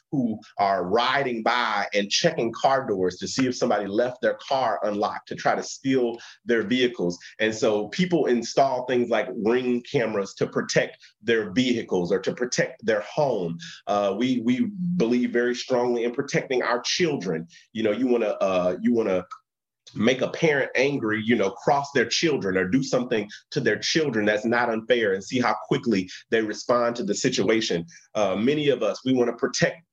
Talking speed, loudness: 185 wpm, -24 LUFS